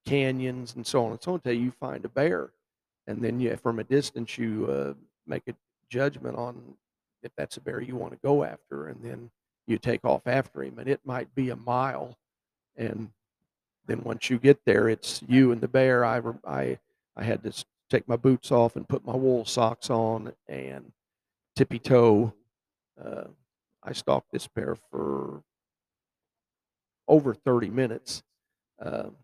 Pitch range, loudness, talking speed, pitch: 110-130 Hz, -27 LUFS, 175 wpm, 120 Hz